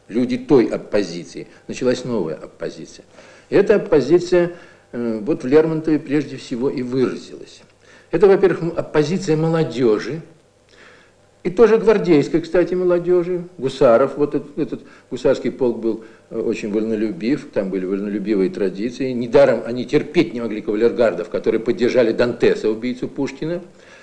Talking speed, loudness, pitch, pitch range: 120 wpm, -19 LUFS, 135 Hz, 115-170 Hz